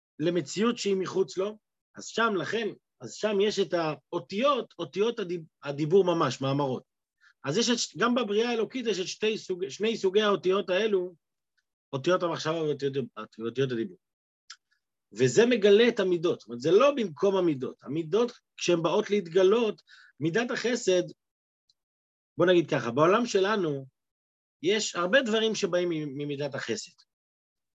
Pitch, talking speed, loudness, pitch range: 180 Hz, 130 wpm, -27 LUFS, 145-210 Hz